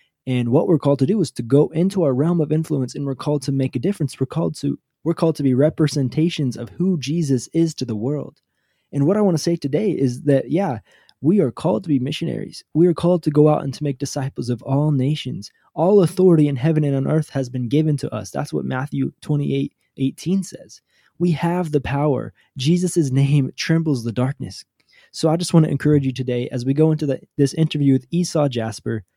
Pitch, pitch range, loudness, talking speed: 145 Hz, 135-165 Hz, -20 LUFS, 225 wpm